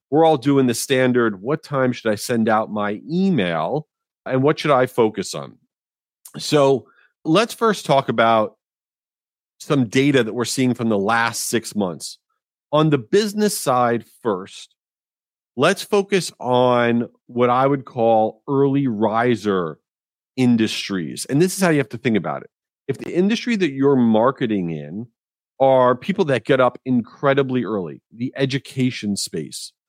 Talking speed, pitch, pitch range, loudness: 155 wpm, 130 Hz, 115-145 Hz, -19 LUFS